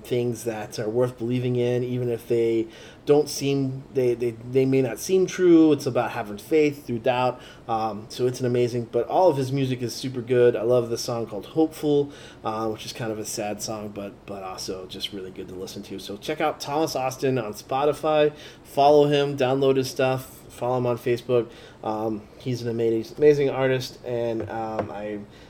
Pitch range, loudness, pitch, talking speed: 115-135 Hz, -24 LUFS, 125 Hz, 200 wpm